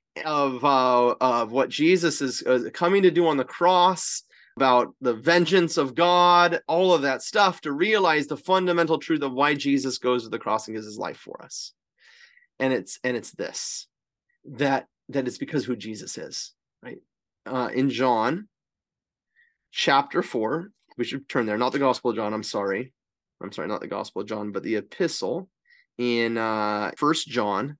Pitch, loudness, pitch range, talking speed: 135 Hz, -24 LUFS, 120-165 Hz, 180 wpm